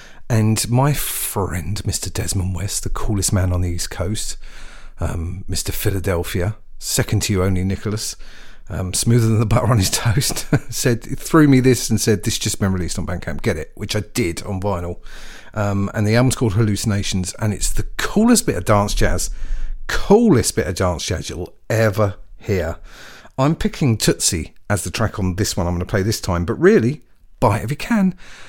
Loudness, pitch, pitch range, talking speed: -19 LUFS, 105 Hz, 95-115 Hz, 190 wpm